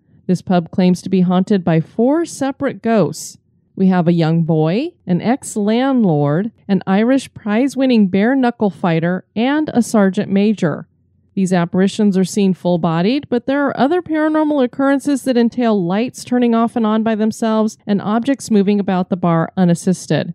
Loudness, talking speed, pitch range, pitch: -16 LUFS, 170 wpm, 180-245 Hz, 205 Hz